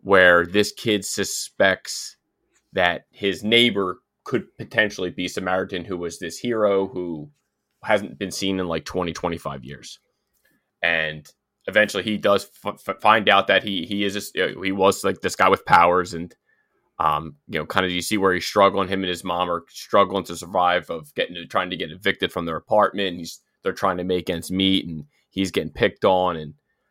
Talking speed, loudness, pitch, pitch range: 190 wpm, -22 LUFS, 90 Hz, 85-100 Hz